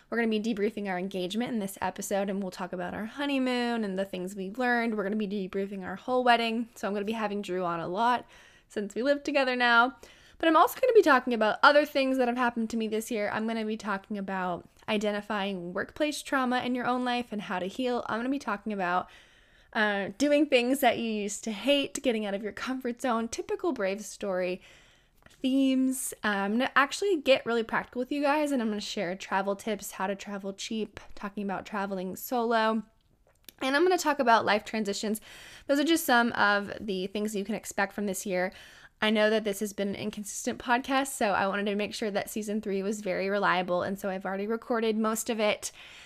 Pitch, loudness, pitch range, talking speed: 215 Hz, -29 LUFS, 200-250 Hz, 230 wpm